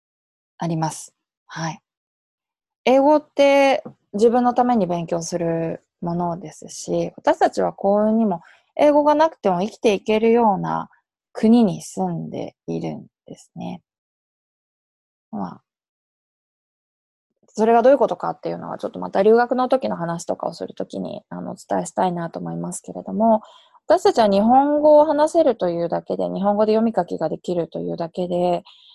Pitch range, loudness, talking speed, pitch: 170-260 Hz, -20 LUFS, 315 characters per minute, 215 Hz